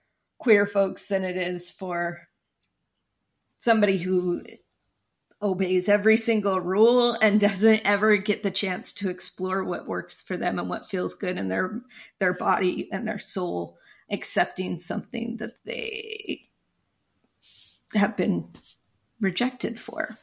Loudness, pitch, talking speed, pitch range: -25 LUFS, 200 Hz, 130 wpm, 185-220 Hz